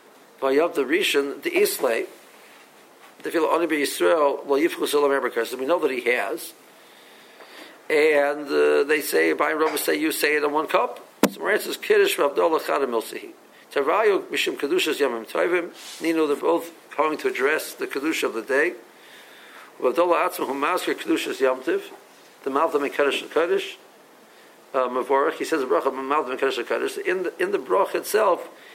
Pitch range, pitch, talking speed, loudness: 325-420 Hz, 390 Hz, 175 wpm, -23 LUFS